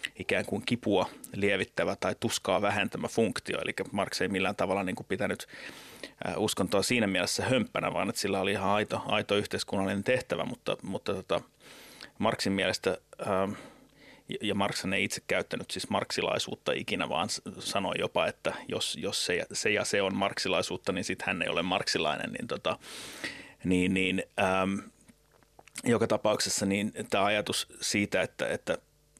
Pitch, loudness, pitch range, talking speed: 100 Hz, -30 LUFS, 95-105 Hz, 150 wpm